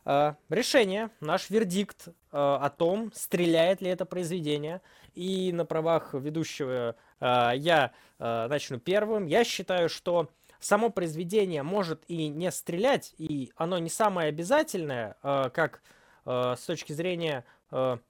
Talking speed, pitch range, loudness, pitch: 135 wpm, 145-185 Hz, -29 LUFS, 165 Hz